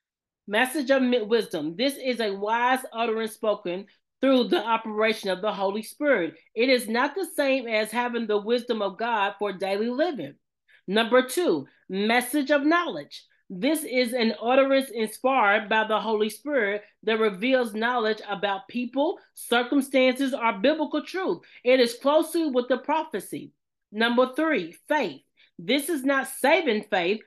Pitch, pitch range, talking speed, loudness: 245 Hz, 215-275 Hz, 145 wpm, -25 LUFS